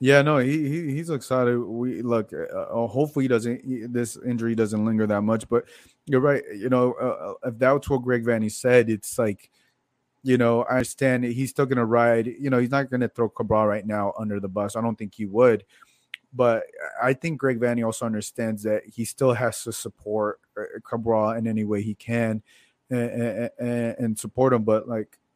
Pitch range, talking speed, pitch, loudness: 110-125 Hz, 200 wpm, 120 Hz, -24 LUFS